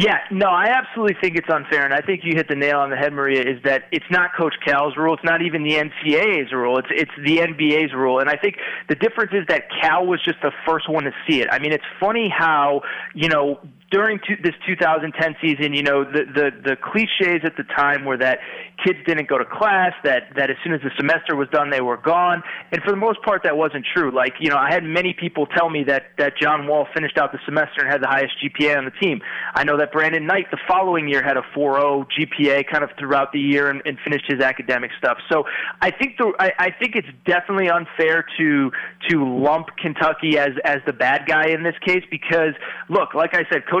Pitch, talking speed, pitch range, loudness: 155 Hz, 240 wpm, 140-175 Hz, -19 LUFS